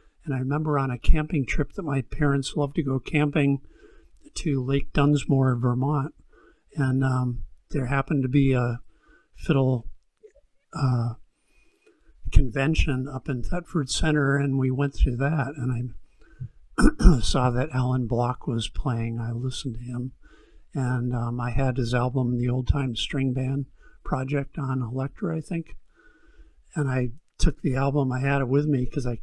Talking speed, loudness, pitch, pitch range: 160 wpm, -26 LUFS, 135 Hz, 125-145 Hz